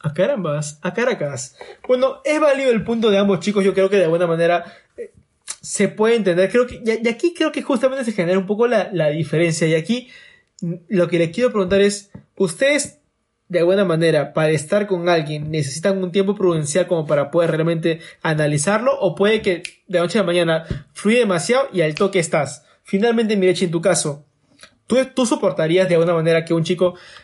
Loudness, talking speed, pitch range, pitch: -18 LUFS, 195 wpm, 165-220 Hz, 185 Hz